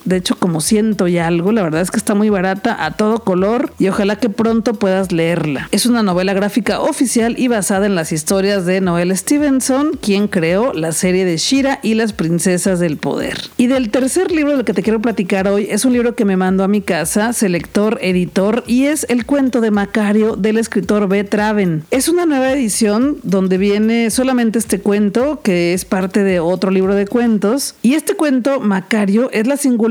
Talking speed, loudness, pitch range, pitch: 205 wpm, -15 LUFS, 190-240 Hz, 215 Hz